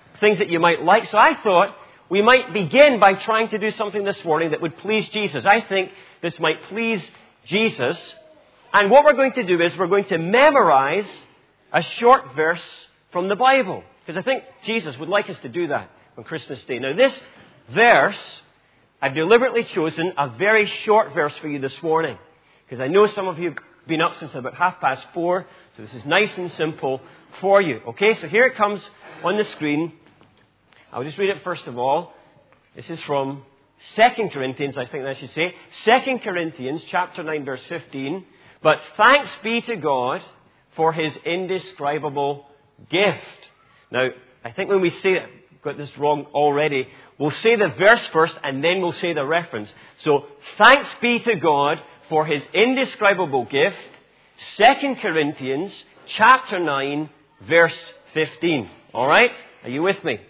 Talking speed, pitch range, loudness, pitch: 175 wpm, 150-210 Hz, -19 LUFS, 175 Hz